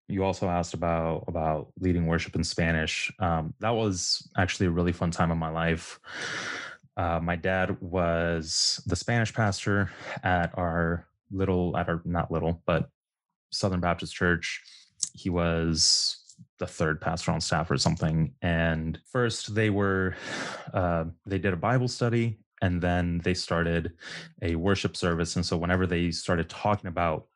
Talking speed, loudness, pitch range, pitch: 155 wpm, -28 LUFS, 85-100 Hz, 90 Hz